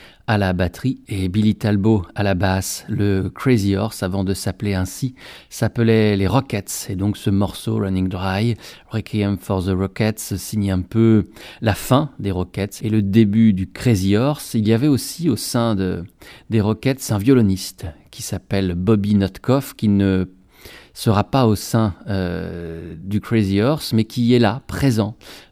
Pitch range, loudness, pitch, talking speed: 95-115 Hz, -19 LUFS, 105 Hz, 170 wpm